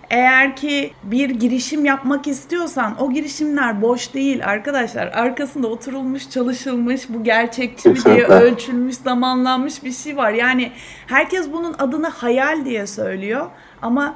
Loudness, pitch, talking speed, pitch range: -18 LUFS, 260 Hz, 130 wpm, 245-280 Hz